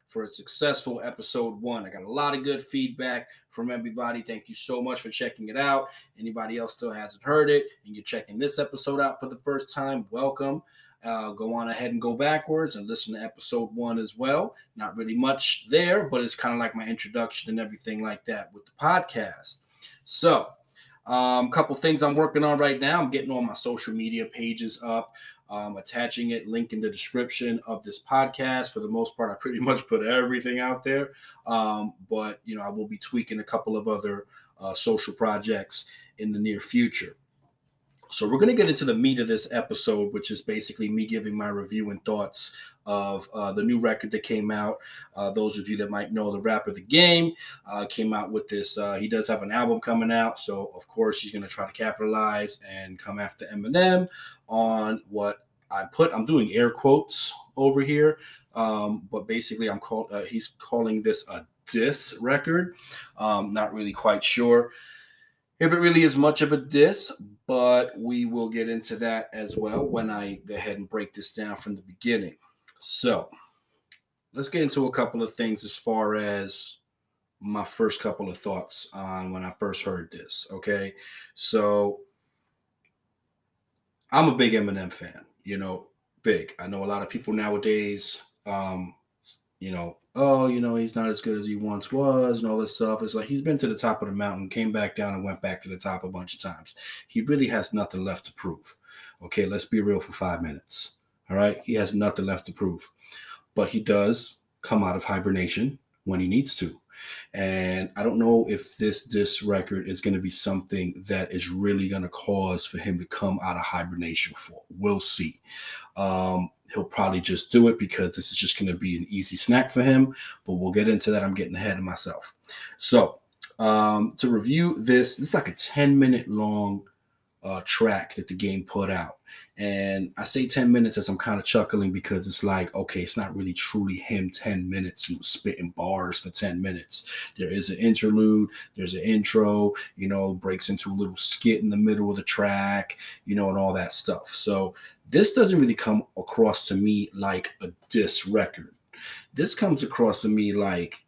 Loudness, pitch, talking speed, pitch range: -26 LUFS, 110 Hz, 200 wpm, 100-130 Hz